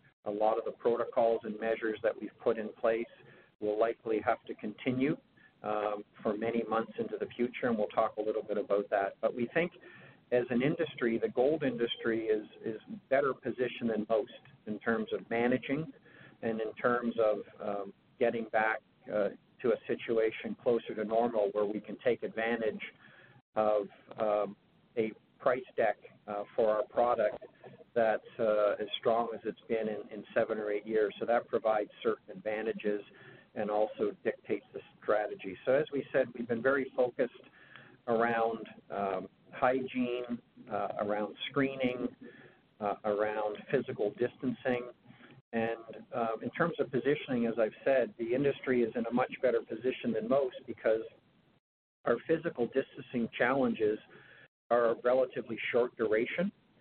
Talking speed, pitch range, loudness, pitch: 155 wpm, 105-125 Hz, -33 LUFS, 115 Hz